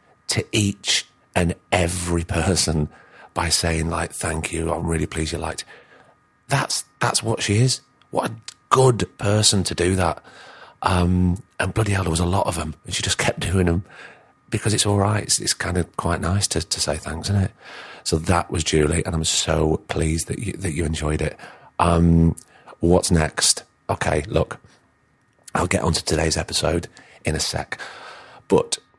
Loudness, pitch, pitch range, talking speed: -21 LUFS, 85 Hz, 80-100 Hz, 180 wpm